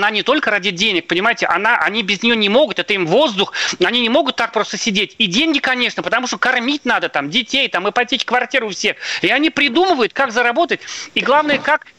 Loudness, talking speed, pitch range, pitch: -15 LUFS, 215 wpm, 215-285 Hz, 245 Hz